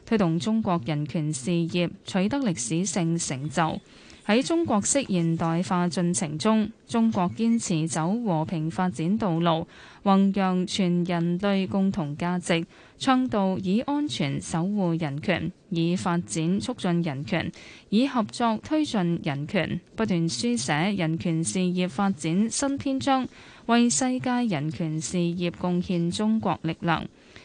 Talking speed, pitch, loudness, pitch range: 205 characters per minute, 180 Hz, -26 LUFS, 170-215 Hz